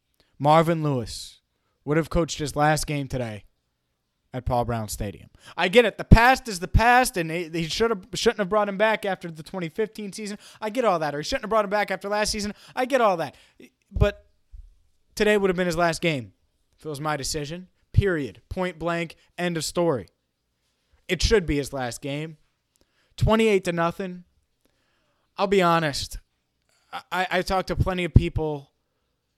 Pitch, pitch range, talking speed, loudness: 165 Hz, 120-195 Hz, 185 wpm, -24 LUFS